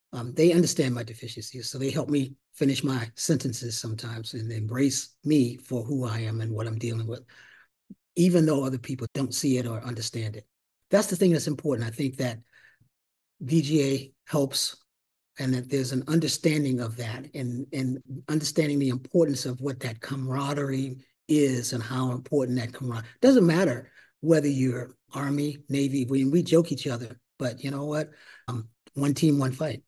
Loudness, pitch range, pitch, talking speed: -27 LUFS, 125-145 Hz, 135 Hz, 175 wpm